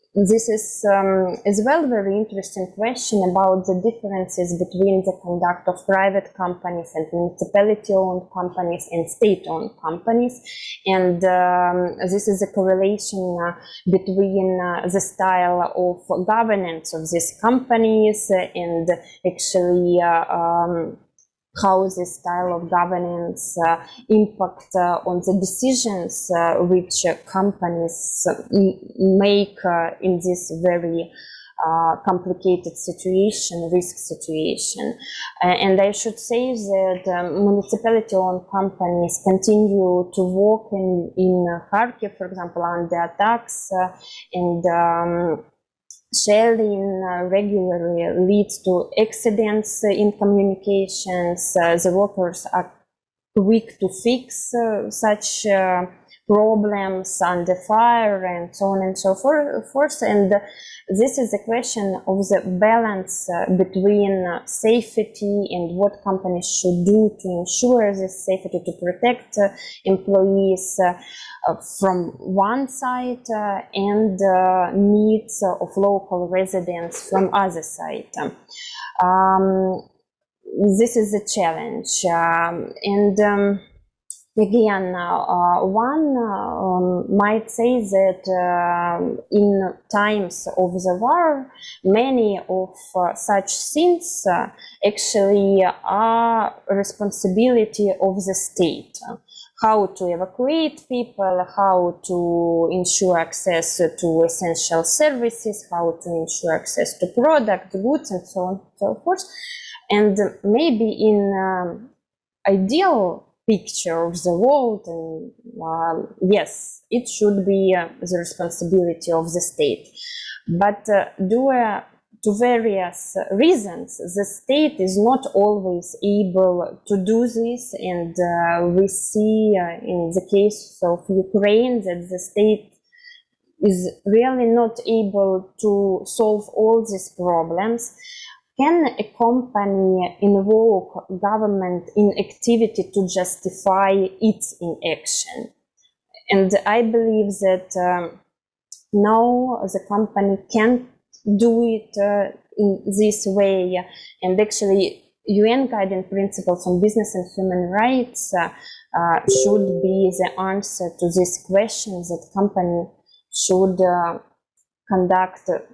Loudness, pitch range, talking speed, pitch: -20 LUFS, 180-215 Hz, 120 wpm, 195 Hz